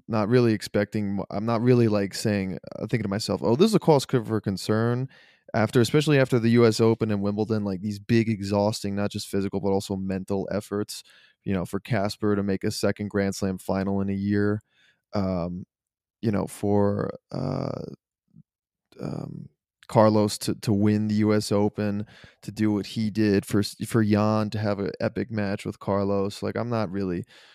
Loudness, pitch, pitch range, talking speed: -25 LUFS, 105 Hz, 100-110 Hz, 175 wpm